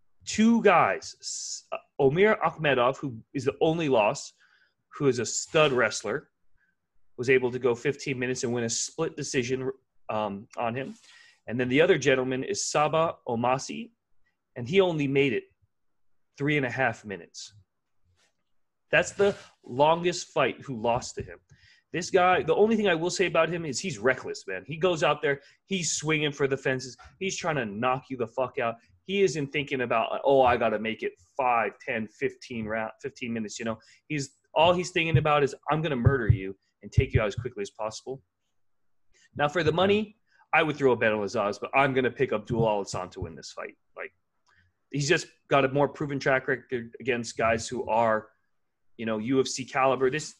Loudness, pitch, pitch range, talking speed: -27 LUFS, 130 Hz, 115-160 Hz, 190 wpm